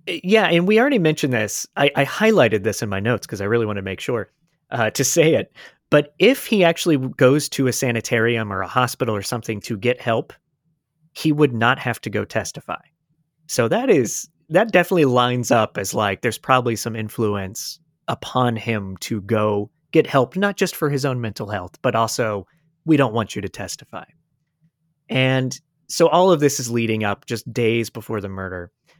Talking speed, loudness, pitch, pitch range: 195 wpm, -20 LUFS, 125 Hz, 110-155 Hz